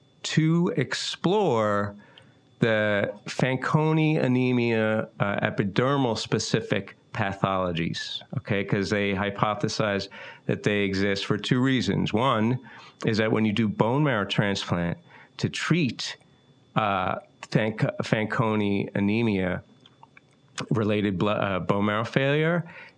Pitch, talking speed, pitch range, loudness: 110 Hz, 105 wpm, 100-135 Hz, -25 LUFS